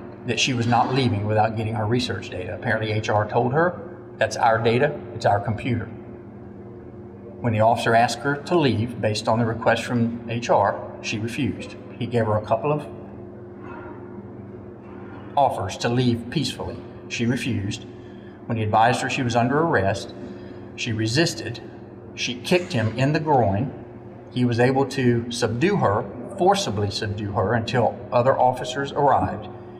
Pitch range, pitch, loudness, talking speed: 110-120 Hz, 115 Hz, -22 LUFS, 155 wpm